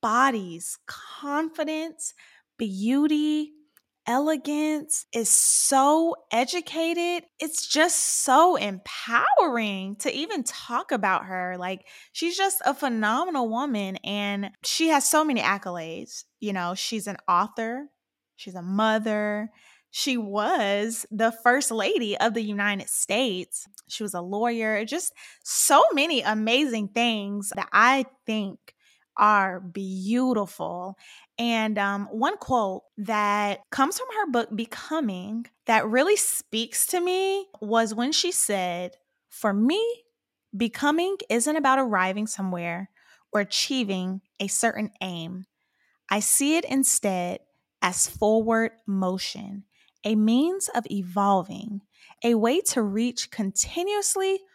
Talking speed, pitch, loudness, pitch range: 115 wpm, 230 Hz, -24 LUFS, 200-290 Hz